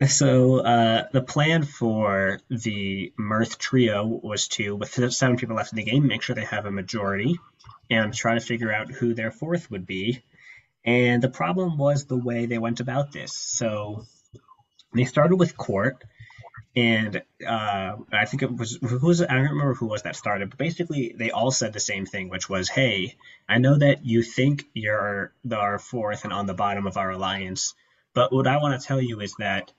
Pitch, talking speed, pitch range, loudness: 115 Hz, 195 wpm, 105-130 Hz, -24 LUFS